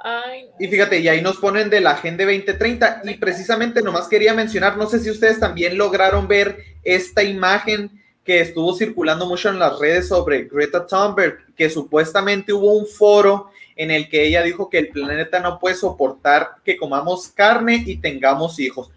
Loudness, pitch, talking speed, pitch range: -17 LUFS, 195 Hz, 175 wpm, 165-210 Hz